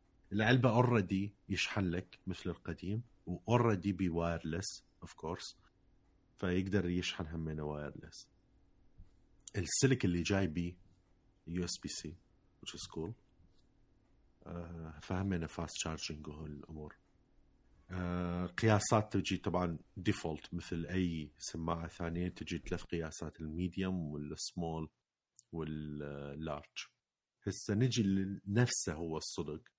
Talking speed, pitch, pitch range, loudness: 100 wpm, 90 Hz, 80-100 Hz, -37 LUFS